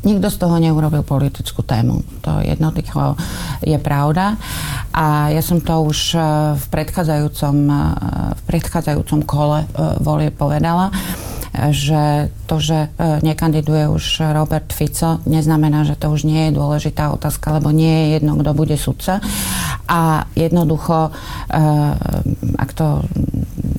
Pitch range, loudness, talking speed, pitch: 150-160 Hz, -17 LUFS, 120 wpm, 155 Hz